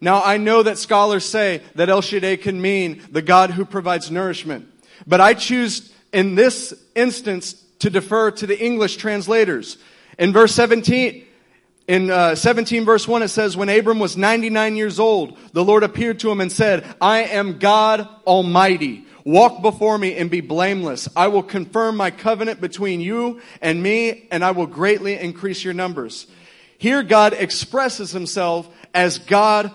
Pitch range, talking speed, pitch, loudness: 185-220 Hz, 165 wpm, 200 Hz, -17 LUFS